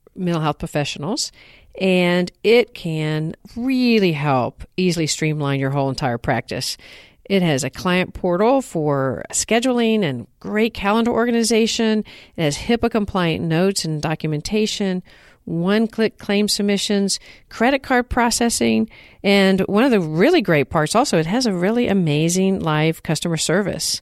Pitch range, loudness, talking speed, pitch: 155-220 Hz, -19 LUFS, 135 wpm, 185 Hz